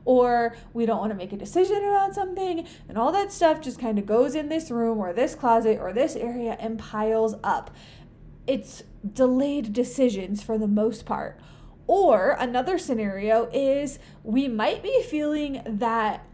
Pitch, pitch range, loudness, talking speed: 245 Hz, 225-290 Hz, -25 LUFS, 165 wpm